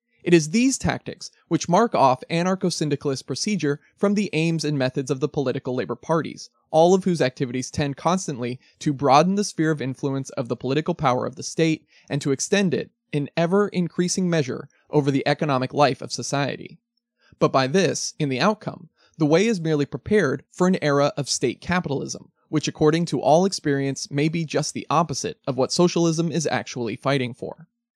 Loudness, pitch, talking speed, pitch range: -23 LUFS, 155 Hz, 180 wpm, 140-175 Hz